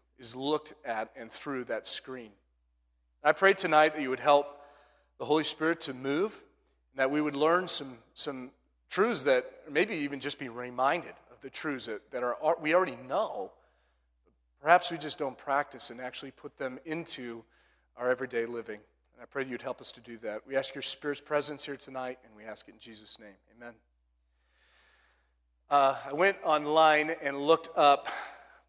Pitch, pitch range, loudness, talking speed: 135 Hz, 115-150 Hz, -29 LUFS, 185 wpm